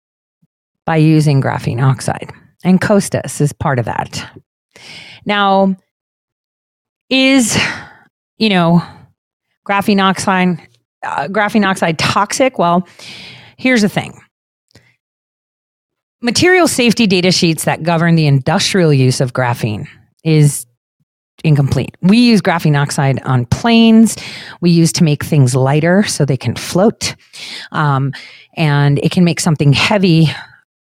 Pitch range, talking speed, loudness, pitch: 140-200 Hz, 115 wpm, -13 LUFS, 165 Hz